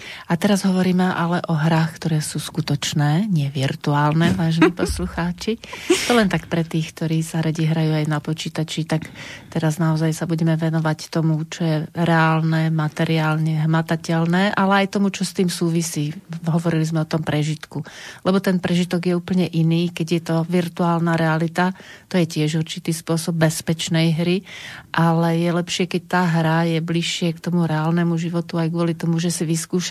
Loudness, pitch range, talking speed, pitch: -20 LUFS, 160-175 Hz, 170 wpm, 165 Hz